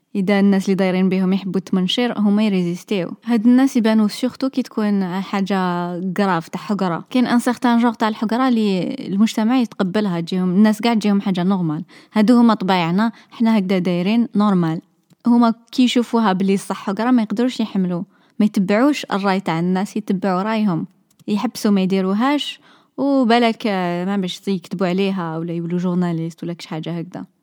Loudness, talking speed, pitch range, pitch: -18 LUFS, 160 wpm, 185-230 Hz, 200 Hz